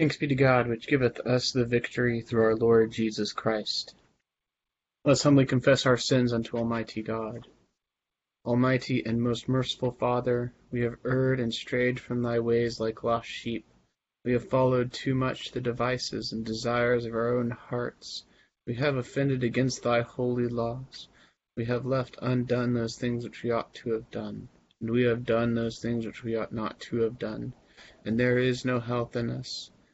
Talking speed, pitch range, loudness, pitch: 180 wpm, 115-125 Hz, -28 LUFS, 120 Hz